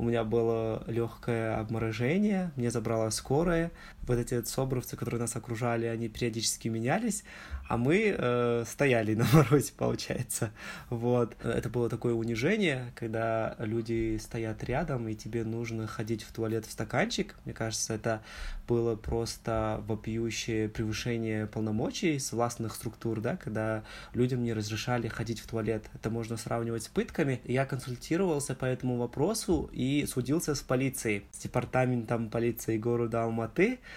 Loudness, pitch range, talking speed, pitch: -31 LUFS, 115-130 Hz, 140 wpm, 115 Hz